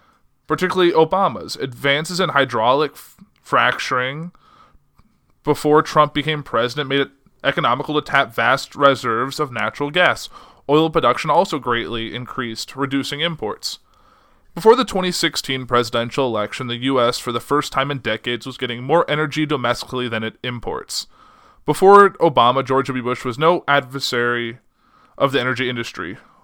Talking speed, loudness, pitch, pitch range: 140 wpm, -18 LUFS, 140 Hz, 125-155 Hz